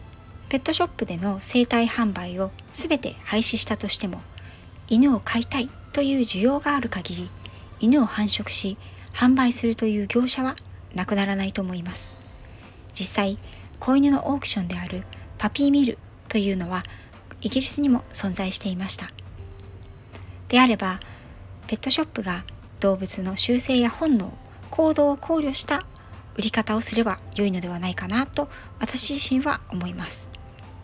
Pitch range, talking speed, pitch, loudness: 175-260 Hz, 305 characters per minute, 215 Hz, -23 LUFS